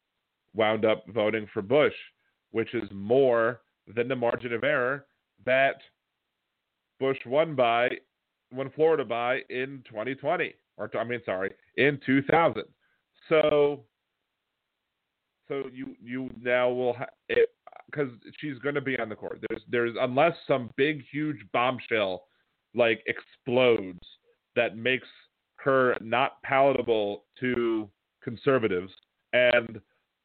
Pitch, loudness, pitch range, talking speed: 125 Hz, -27 LUFS, 115-140 Hz, 120 wpm